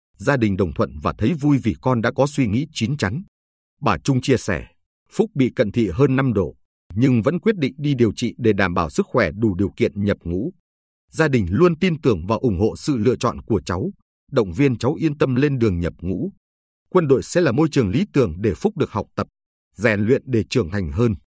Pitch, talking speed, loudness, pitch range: 115 Hz, 235 wpm, -20 LUFS, 100-140 Hz